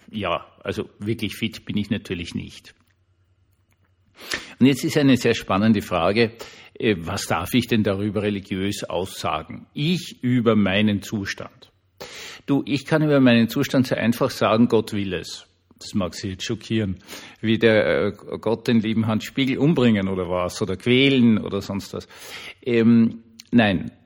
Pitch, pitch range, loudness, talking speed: 110 Hz, 100-120 Hz, -21 LUFS, 150 wpm